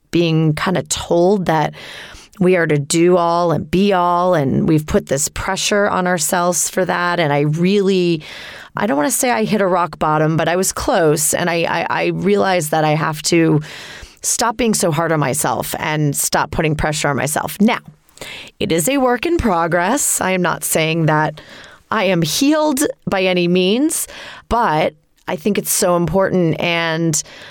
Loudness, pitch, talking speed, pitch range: -16 LUFS, 175 Hz, 185 wpm, 160-190 Hz